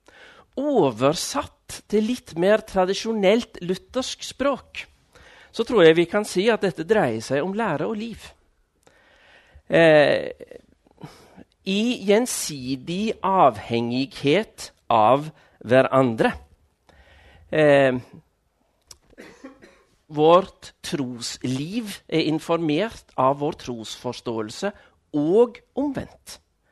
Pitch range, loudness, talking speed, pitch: 130-220 Hz, -22 LUFS, 85 wpm, 175 Hz